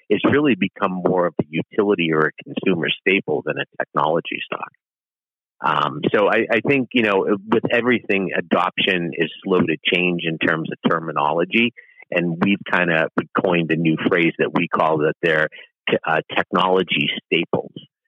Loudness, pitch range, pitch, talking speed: -19 LUFS, 85-105 Hz, 95 Hz, 165 wpm